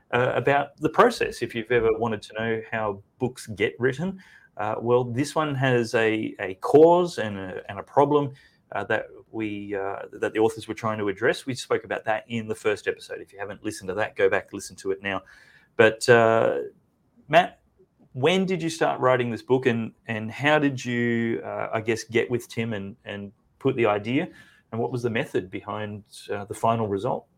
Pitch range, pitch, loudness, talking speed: 110-140 Hz, 120 Hz, -25 LUFS, 205 wpm